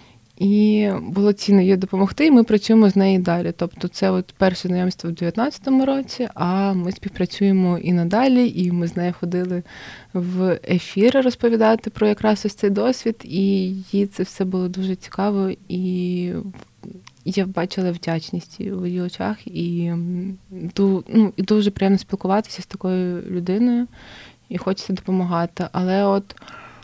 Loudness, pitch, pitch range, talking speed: -20 LUFS, 190 Hz, 180-205 Hz, 150 wpm